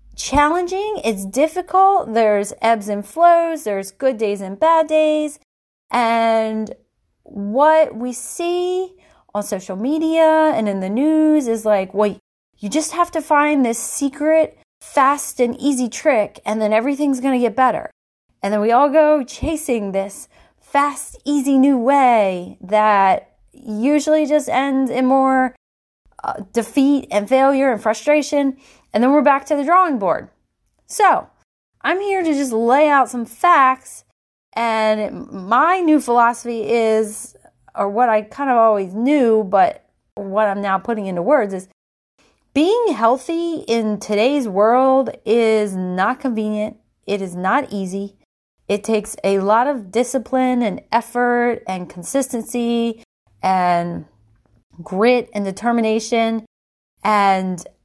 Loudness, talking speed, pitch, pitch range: -17 LUFS, 135 wpm, 240 Hz, 210-290 Hz